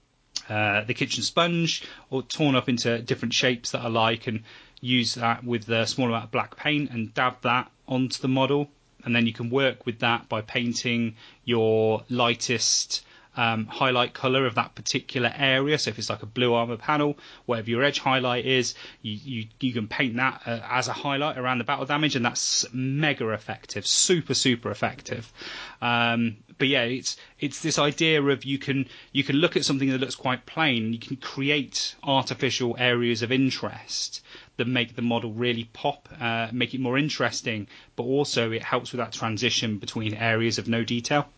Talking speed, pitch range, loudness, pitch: 190 wpm, 115-135 Hz, -25 LUFS, 125 Hz